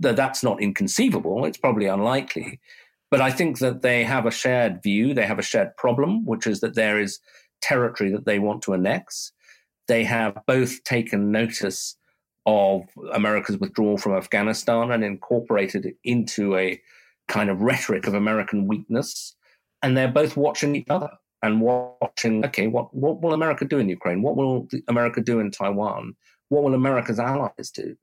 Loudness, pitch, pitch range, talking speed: -23 LUFS, 120 Hz, 105-135 Hz, 170 wpm